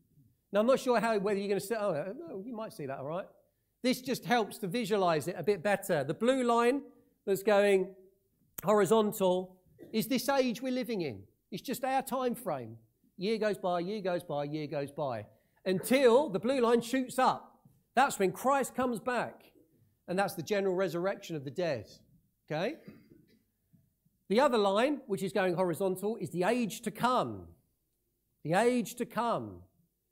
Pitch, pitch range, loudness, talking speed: 200 Hz, 175-235 Hz, -31 LUFS, 175 wpm